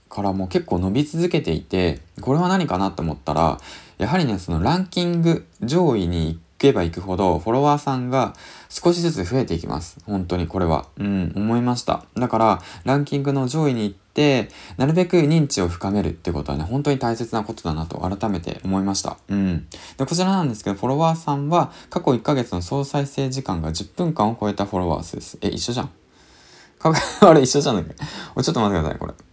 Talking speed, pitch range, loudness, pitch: 410 characters per minute, 90-140 Hz, -21 LUFS, 105 Hz